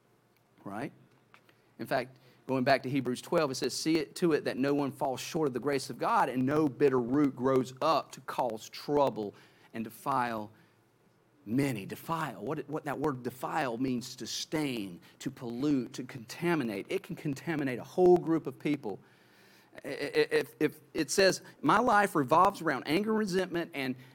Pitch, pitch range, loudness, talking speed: 140 Hz, 125-160 Hz, -31 LUFS, 170 wpm